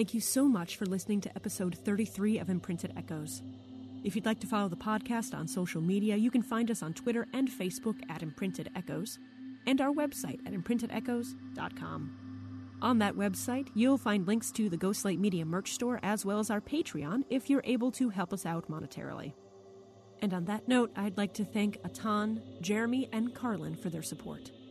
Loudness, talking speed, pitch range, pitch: -34 LUFS, 190 wpm, 185-240 Hz, 210 Hz